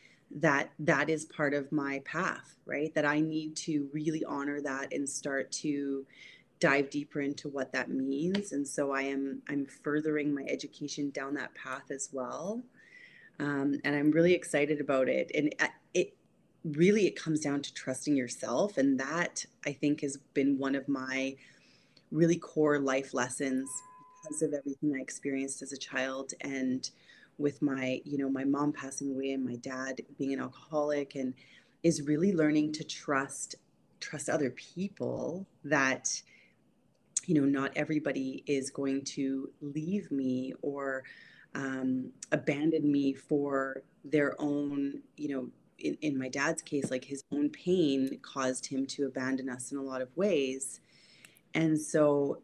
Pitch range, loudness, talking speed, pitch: 135-150 Hz, -33 LUFS, 160 wpm, 140 Hz